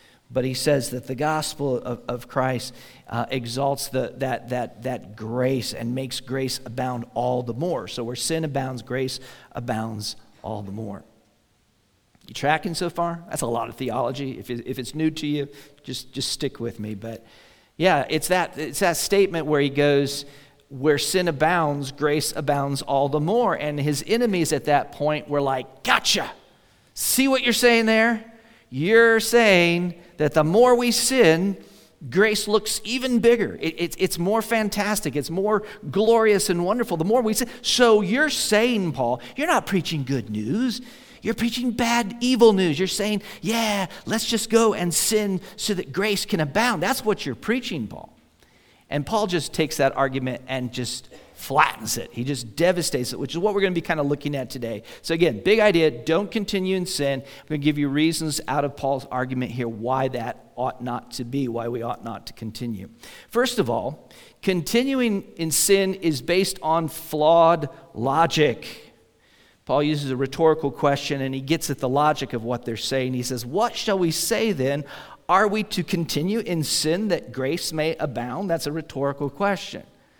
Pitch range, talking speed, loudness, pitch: 130-200 Hz, 185 wpm, -23 LUFS, 150 Hz